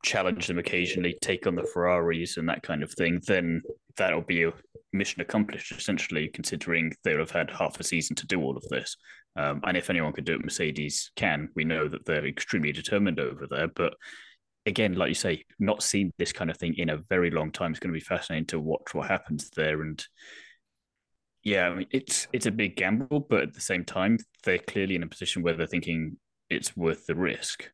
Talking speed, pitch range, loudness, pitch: 215 wpm, 80-95 Hz, -29 LUFS, 85 Hz